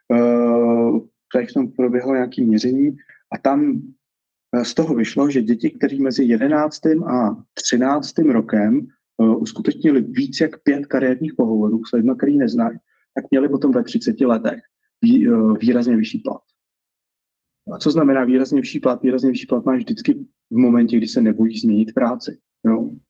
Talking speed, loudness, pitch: 150 wpm, -18 LUFS, 135 Hz